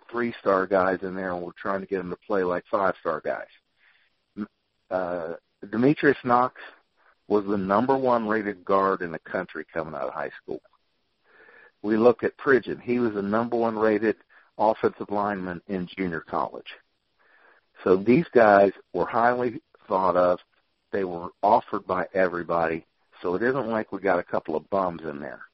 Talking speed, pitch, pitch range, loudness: 170 wpm, 100 Hz, 95-115 Hz, -25 LUFS